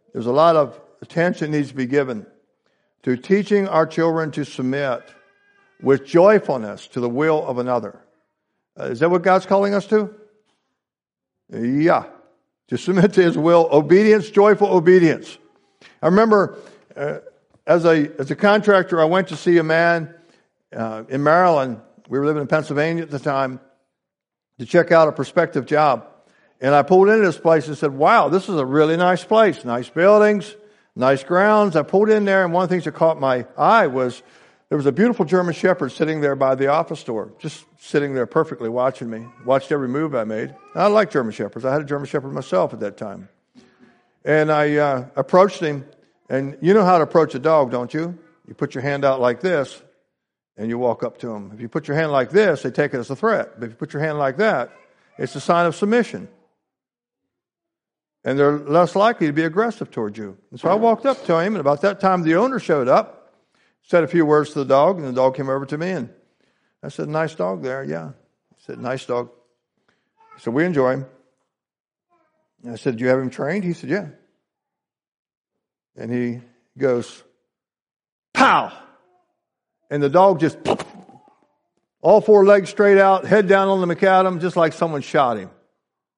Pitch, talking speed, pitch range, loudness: 155 Hz, 195 wpm, 135-190 Hz, -18 LUFS